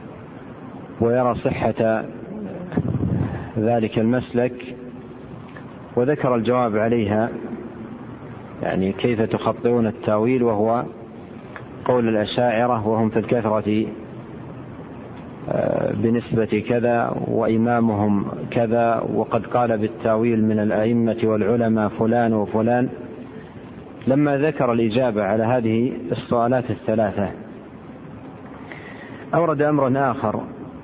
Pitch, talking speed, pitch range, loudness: 115 Hz, 75 wpm, 110-125 Hz, -21 LUFS